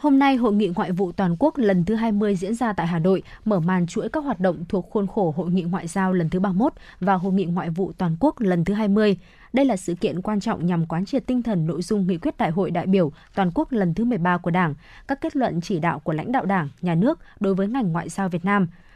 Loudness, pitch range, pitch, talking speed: -23 LUFS, 180-220 Hz, 195 Hz, 270 wpm